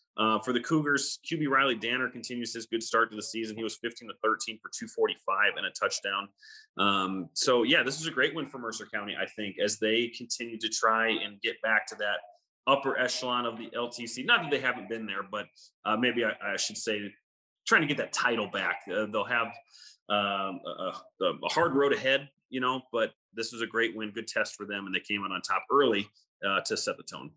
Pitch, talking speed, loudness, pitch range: 115 Hz, 230 wpm, -29 LUFS, 110-130 Hz